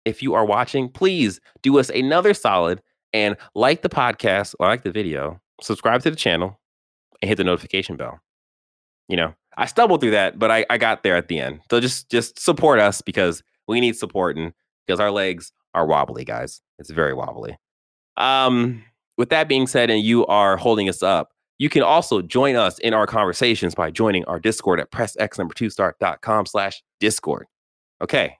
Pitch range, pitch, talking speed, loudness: 95-120 Hz, 110 Hz, 185 wpm, -20 LUFS